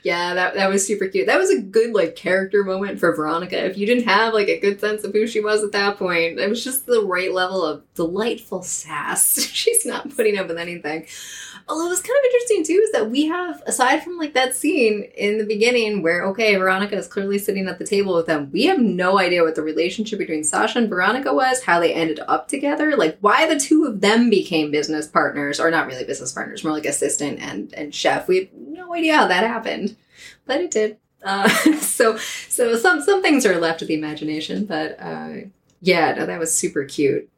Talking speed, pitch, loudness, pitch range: 225 wpm, 205 Hz, -19 LUFS, 175-280 Hz